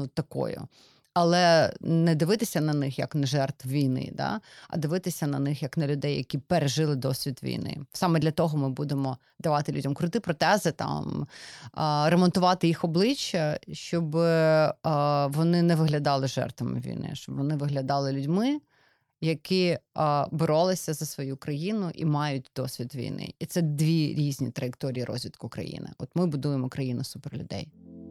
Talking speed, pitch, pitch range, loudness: 145 wpm, 150 Hz, 140-165 Hz, -27 LUFS